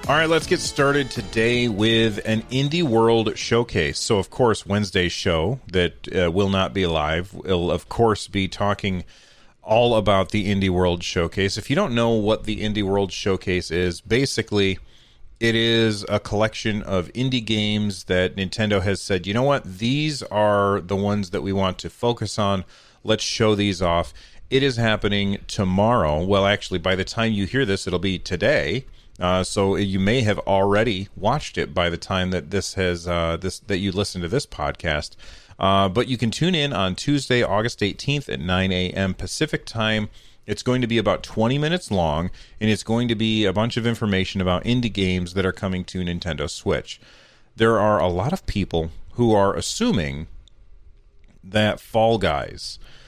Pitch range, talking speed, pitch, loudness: 95-115 Hz, 185 wpm, 100 Hz, -22 LUFS